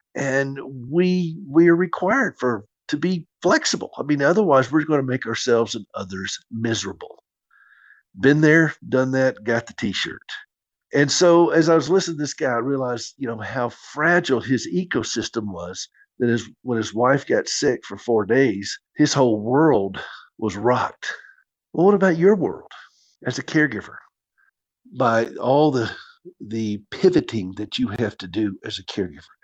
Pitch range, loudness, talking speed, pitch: 115-165 Hz, -21 LUFS, 165 wpm, 135 Hz